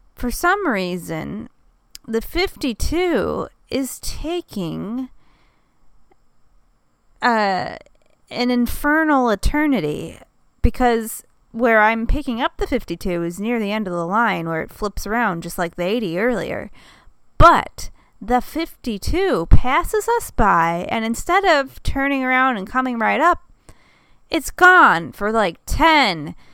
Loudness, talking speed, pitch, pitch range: -19 LUFS, 120 wpm, 245 Hz, 210-300 Hz